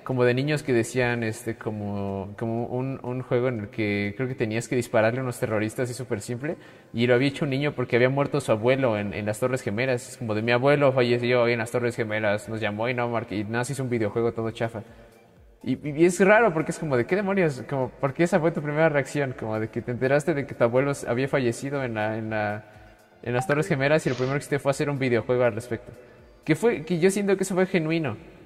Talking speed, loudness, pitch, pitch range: 245 wpm, -25 LUFS, 125 Hz, 115-140 Hz